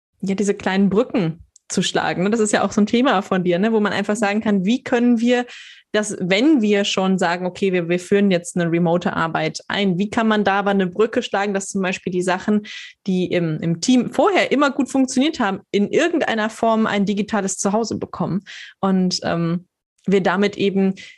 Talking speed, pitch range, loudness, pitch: 205 wpm, 185-220 Hz, -19 LUFS, 200 Hz